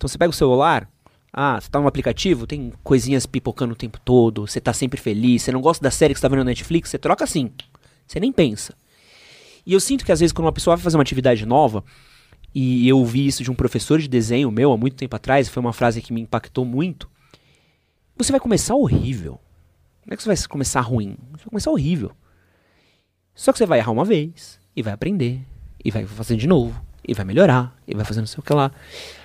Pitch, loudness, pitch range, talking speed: 130 Hz, -20 LUFS, 120-155 Hz, 230 wpm